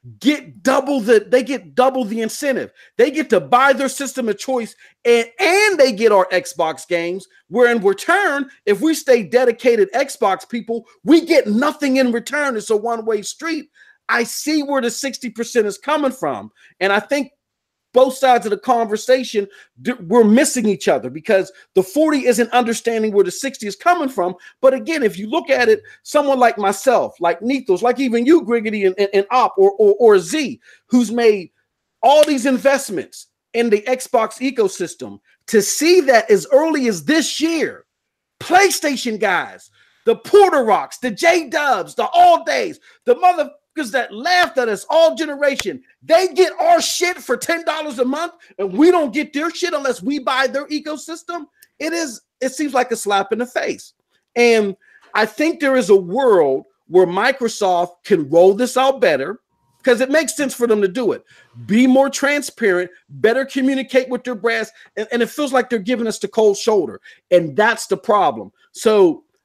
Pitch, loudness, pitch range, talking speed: 255 Hz, -17 LUFS, 215-300 Hz, 185 wpm